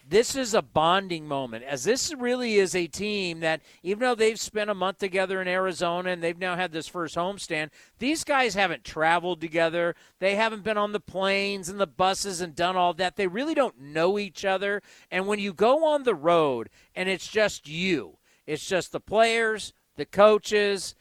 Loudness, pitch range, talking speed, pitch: -26 LUFS, 170-210 Hz, 195 wpm, 190 Hz